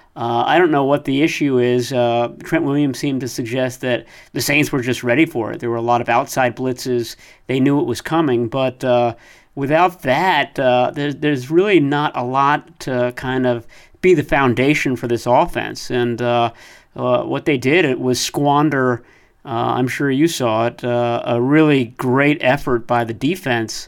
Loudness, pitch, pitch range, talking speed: -17 LUFS, 130 Hz, 120-145 Hz, 195 wpm